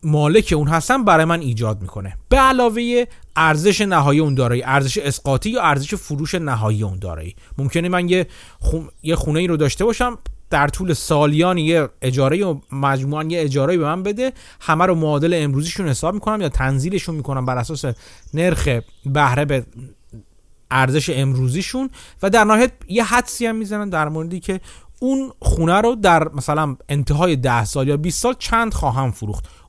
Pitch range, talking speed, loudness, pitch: 135-185 Hz, 170 wpm, -18 LUFS, 155 Hz